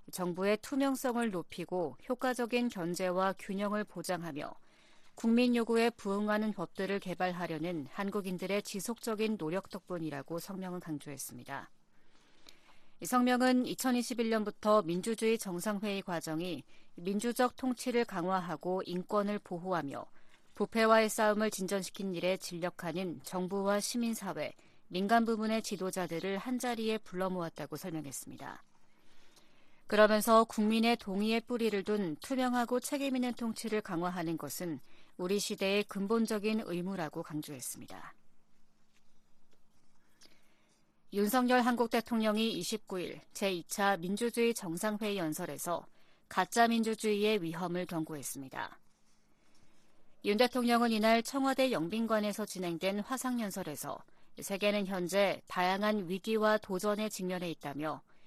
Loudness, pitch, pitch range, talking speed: -34 LUFS, 200 Hz, 180-225 Hz, 295 characters per minute